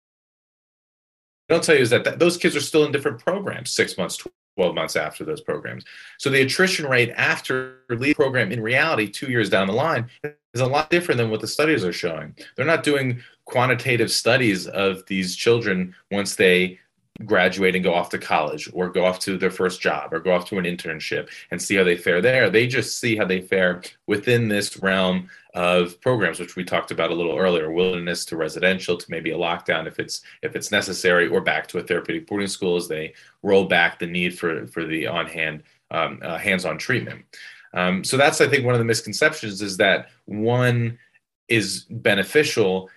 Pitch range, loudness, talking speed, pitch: 90-125 Hz, -21 LUFS, 200 wpm, 100 Hz